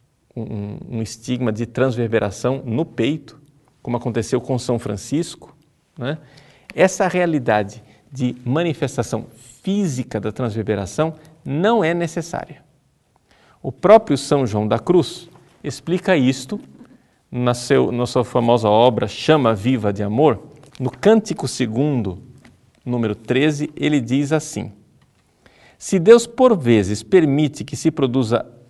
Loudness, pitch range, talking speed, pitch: -19 LUFS, 120-155 Hz, 120 wpm, 130 Hz